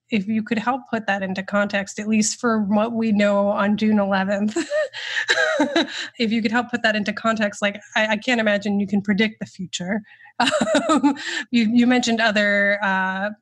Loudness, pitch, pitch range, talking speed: -20 LUFS, 215 Hz, 205-240 Hz, 180 wpm